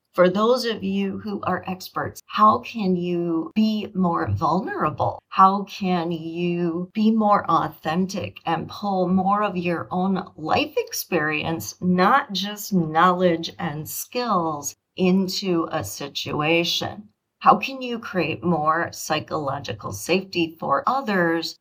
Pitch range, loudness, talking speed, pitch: 165-205 Hz, -22 LUFS, 120 wpm, 180 Hz